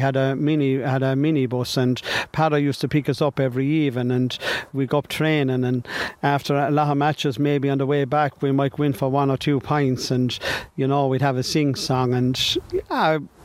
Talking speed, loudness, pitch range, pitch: 220 wpm, -22 LUFS, 130-145 Hz, 140 Hz